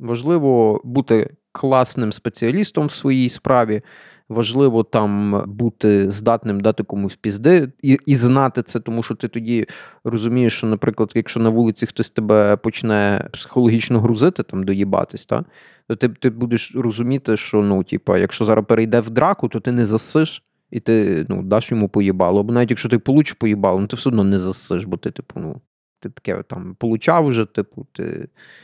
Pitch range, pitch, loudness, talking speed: 110-125 Hz, 115 Hz, -18 LUFS, 175 wpm